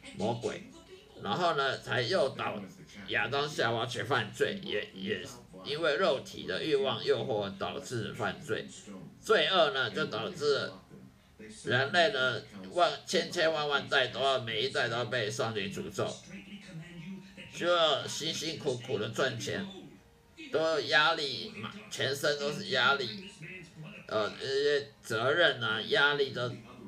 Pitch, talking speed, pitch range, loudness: 185 Hz, 190 characters per minute, 160-215 Hz, -31 LUFS